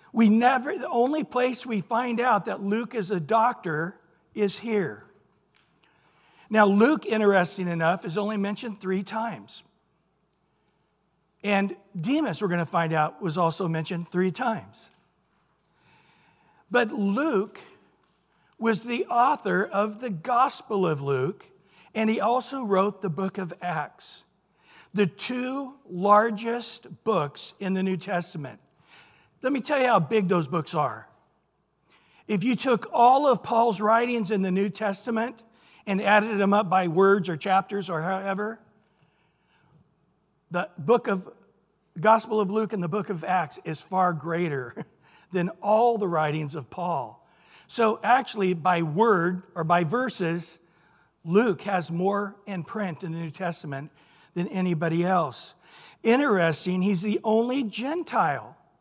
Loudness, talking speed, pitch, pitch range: -25 LUFS, 140 wpm, 200 Hz, 175-220 Hz